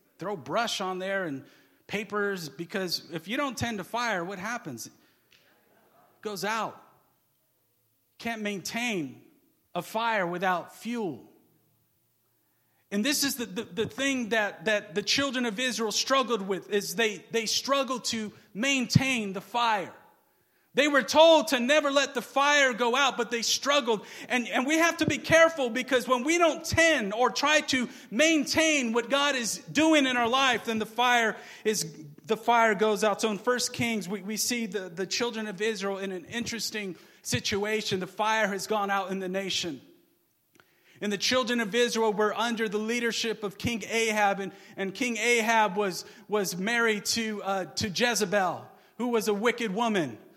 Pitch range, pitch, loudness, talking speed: 205-250 Hz, 225 Hz, -27 LUFS, 170 wpm